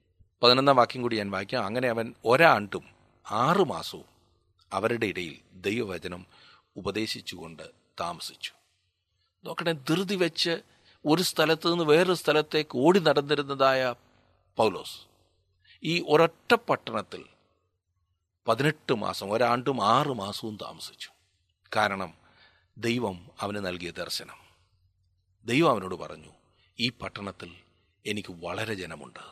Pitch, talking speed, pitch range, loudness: 105 Hz, 95 wpm, 90-140 Hz, -27 LUFS